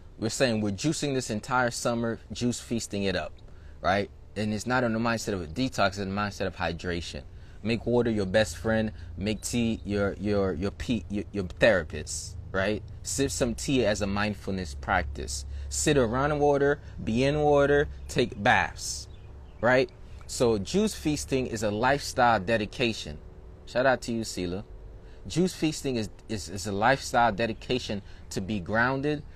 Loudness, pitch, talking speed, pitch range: -28 LUFS, 105 Hz, 165 wpm, 90-120 Hz